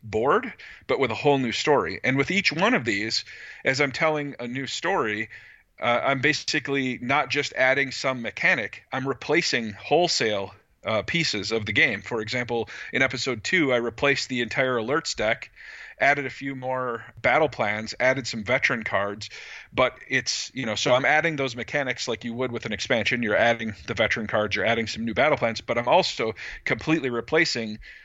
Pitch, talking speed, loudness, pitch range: 130 Hz, 185 wpm, -24 LUFS, 115-140 Hz